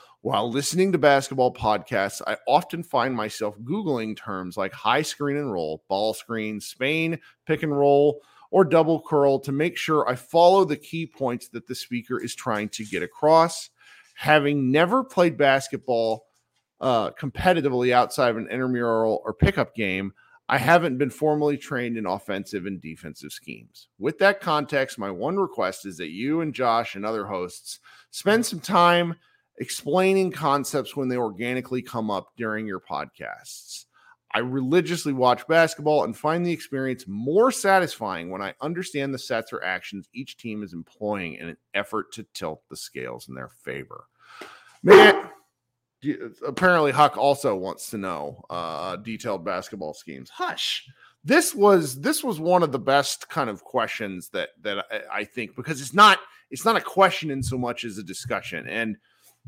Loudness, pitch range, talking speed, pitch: -23 LUFS, 115-165 Hz, 165 wpm, 135 Hz